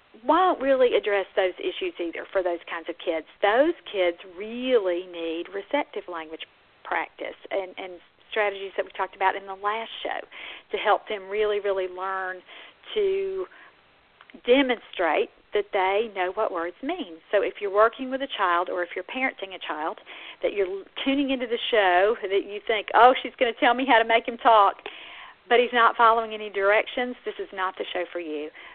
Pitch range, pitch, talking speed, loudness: 185-260 Hz, 210 Hz, 185 wpm, -25 LUFS